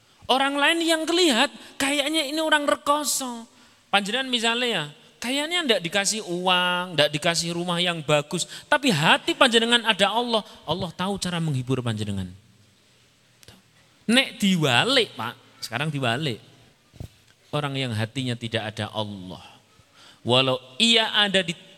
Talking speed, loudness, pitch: 125 wpm, -22 LUFS, 180 Hz